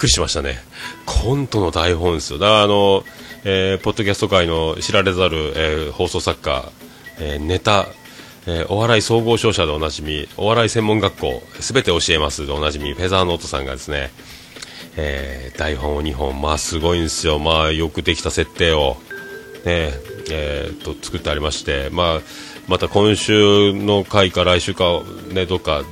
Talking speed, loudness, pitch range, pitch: 335 characters per minute, -18 LUFS, 75-100 Hz, 90 Hz